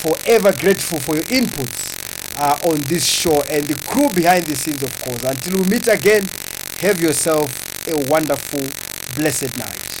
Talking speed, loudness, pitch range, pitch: 160 wpm, -18 LUFS, 140-180 Hz, 155 Hz